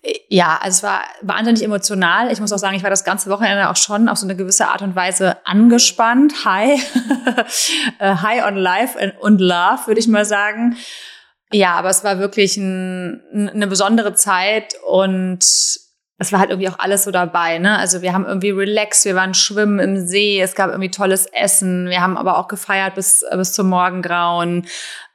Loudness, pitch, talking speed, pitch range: -15 LUFS, 200 Hz, 185 wpm, 185-215 Hz